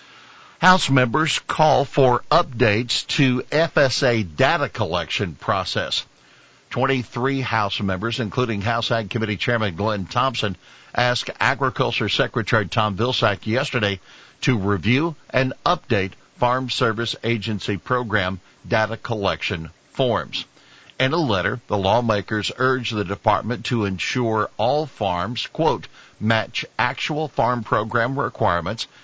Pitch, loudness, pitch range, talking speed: 120 Hz, -21 LUFS, 105-130 Hz, 115 wpm